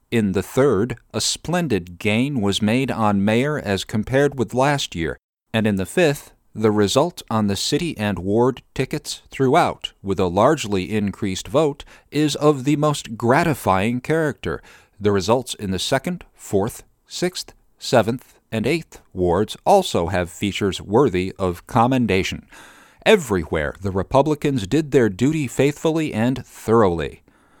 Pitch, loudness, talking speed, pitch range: 115 Hz, -20 LUFS, 140 wpm, 100-145 Hz